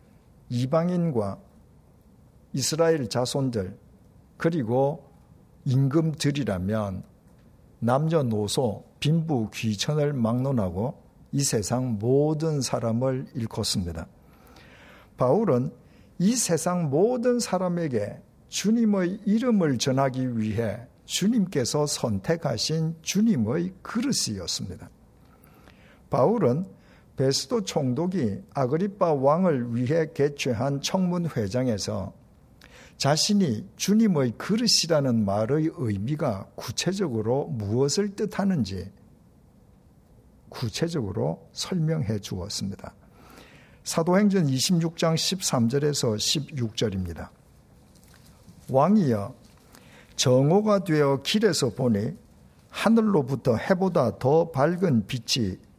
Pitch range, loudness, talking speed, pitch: 115-170 Hz, -25 LUFS, 205 characters per minute, 140 Hz